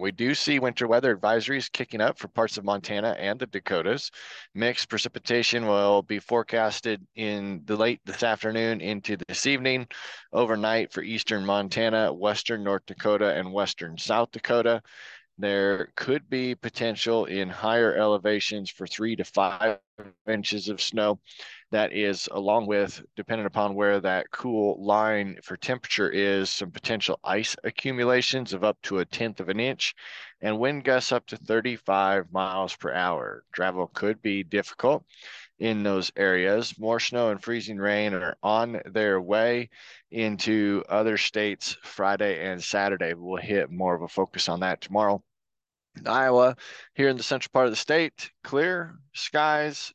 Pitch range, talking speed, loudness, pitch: 100-120 Hz, 155 wpm, -26 LUFS, 110 Hz